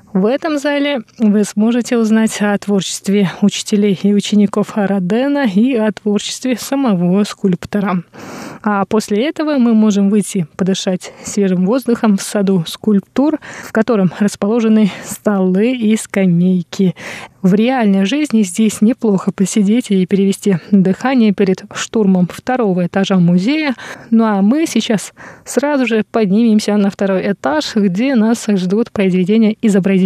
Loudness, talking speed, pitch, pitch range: -14 LUFS, 130 wpm, 210 Hz, 195-230 Hz